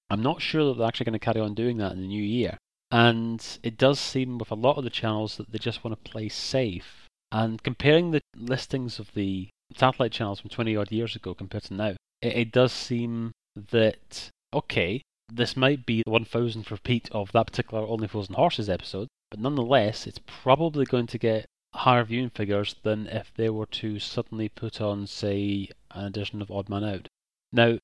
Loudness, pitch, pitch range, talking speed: -27 LUFS, 115 Hz, 105-120 Hz, 200 wpm